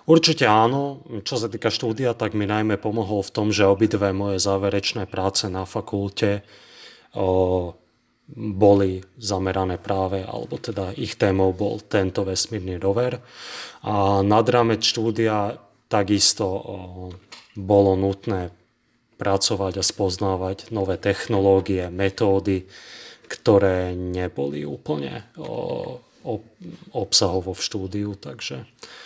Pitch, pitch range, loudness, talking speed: 100 Hz, 95-110 Hz, -22 LUFS, 110 wpm